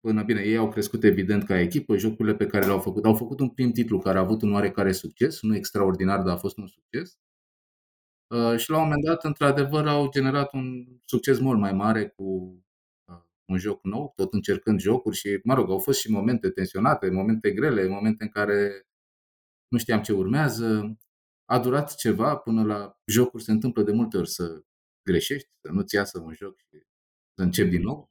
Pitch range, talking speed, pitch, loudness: 100-125 Hz, 195 wpm, 110 Hz, -25 LUFS